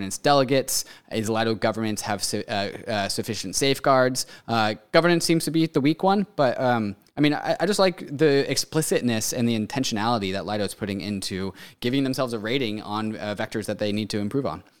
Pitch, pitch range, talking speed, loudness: 115 Hz, 105-140 Hz, 200 wpm, -24 LUFS